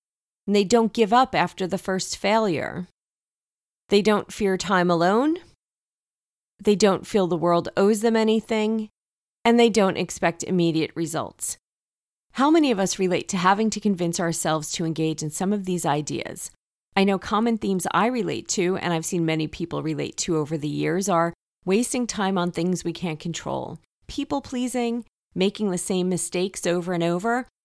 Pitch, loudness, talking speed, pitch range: 190 Hz, -23 LUFS, 170 wpm, 170-215 Hz